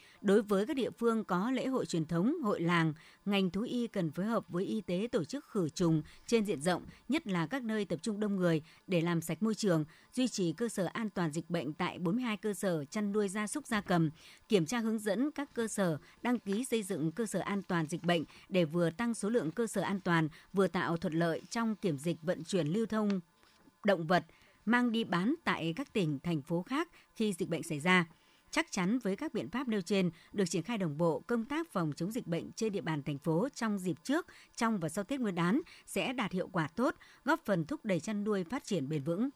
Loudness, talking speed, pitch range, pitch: -34 LUFS, 245 wpm, 170-230 Hz, 195 Hz